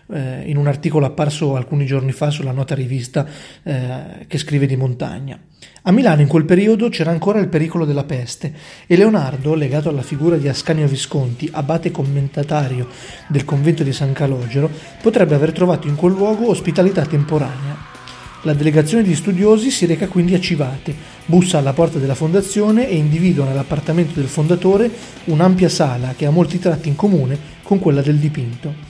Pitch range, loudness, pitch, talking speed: 140-175 Hz, -16 LUFS, 155 Hz, 165 wpm